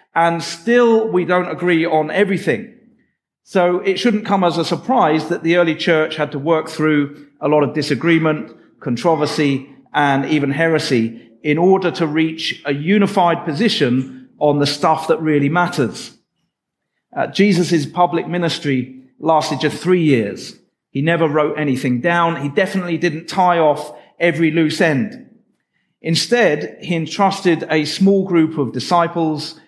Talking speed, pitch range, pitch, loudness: 145 wpm, 150-180 Hz, 165 Hz, -17 LUFS